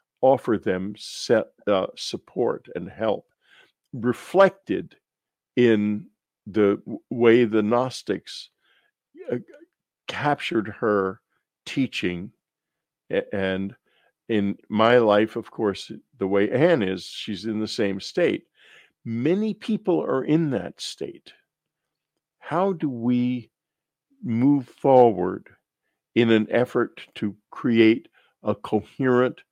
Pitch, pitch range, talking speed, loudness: 115 Hz, 105-135 Hz, 100 wpm, -23 LUFS